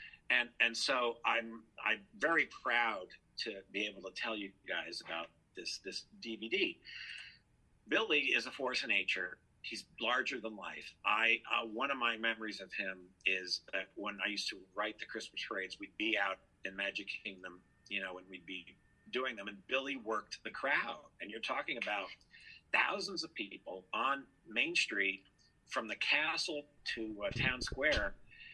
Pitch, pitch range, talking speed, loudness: 100 Hz, 95-115 Hz, 170 wpm, -36 LUFS